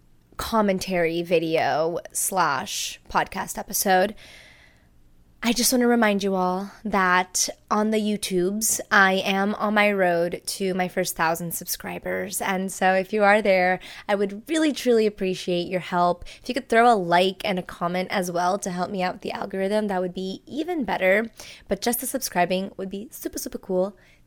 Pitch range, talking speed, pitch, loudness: 180-215 Hz, 175 wpm, 190 Hz, -23 LUFS